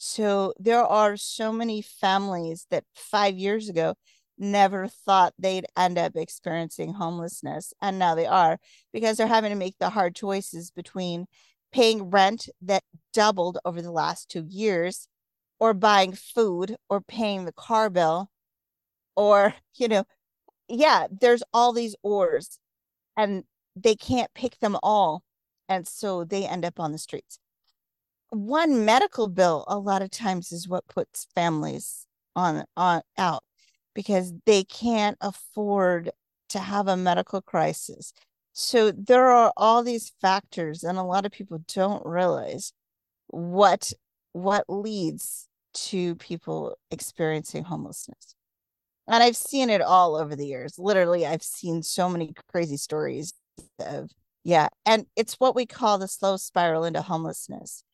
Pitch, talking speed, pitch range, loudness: 195 Hz, 145 wpm, 175-220 Hz, -24 LUFS